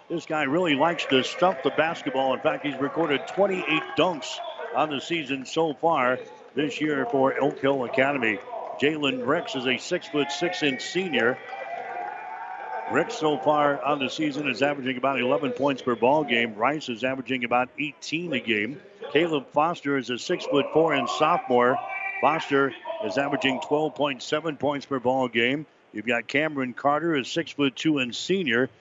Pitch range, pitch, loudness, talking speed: 130-160 Hz, 140 Hz, -25 LUFS, 150 wpm